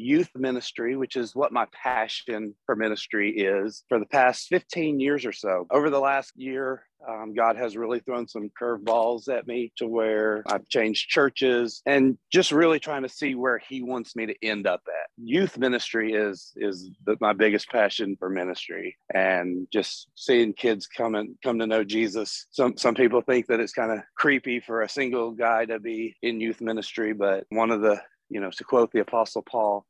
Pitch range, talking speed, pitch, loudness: 110-130 Hz, 200 wpm, 115 Hz, -25 LUFS